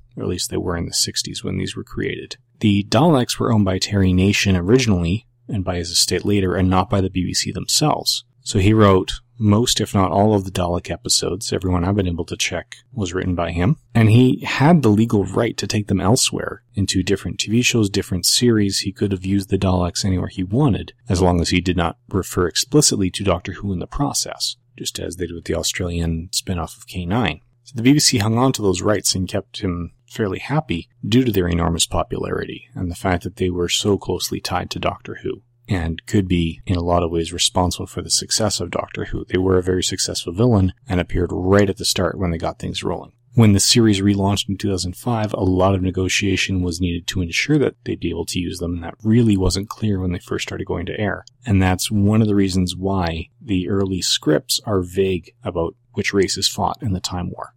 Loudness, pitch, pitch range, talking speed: -19 LUFS, 95 Hz, 90-110 Hz, 225 wpm